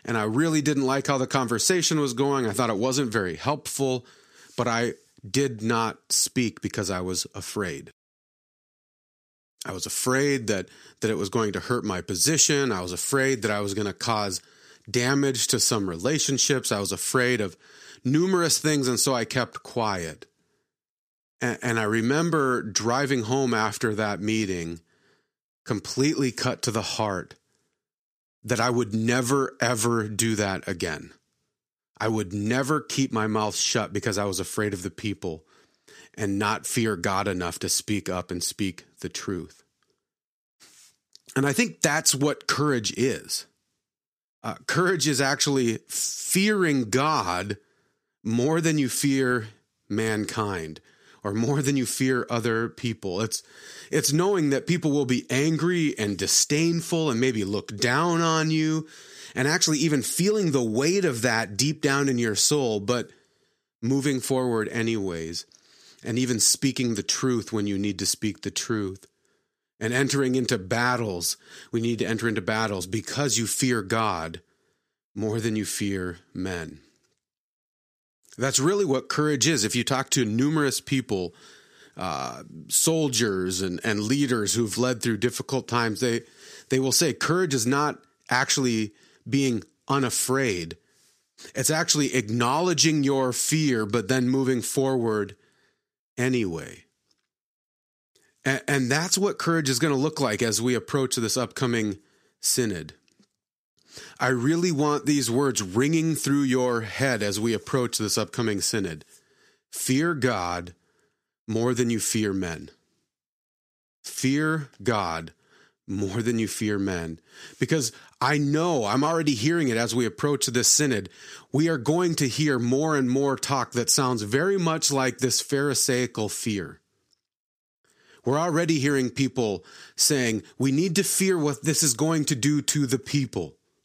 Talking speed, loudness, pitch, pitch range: 150 wpm, -25 LUFS, 125 Hz, 110-140 Hz